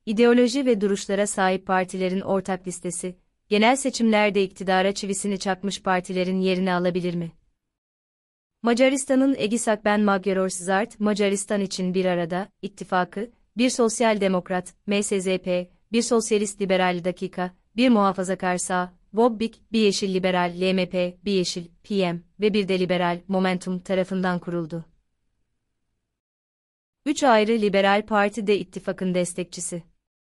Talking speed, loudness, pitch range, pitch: 115 wpm, -23 LUFS, 180-210 Hz, 190 Hz